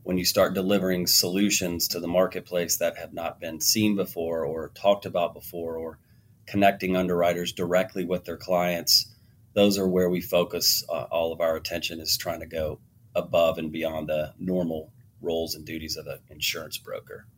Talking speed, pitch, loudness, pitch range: 175 wpm, 90 Hz, -25 LUFS, 85-100 Hz